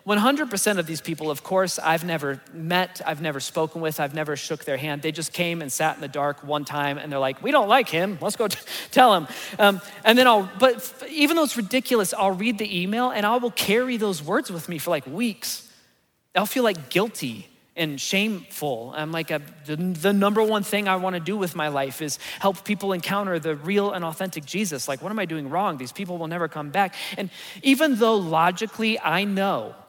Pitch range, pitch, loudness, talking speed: 155-210 Hz, 185 Hz, -23 LUFS, 225 wpm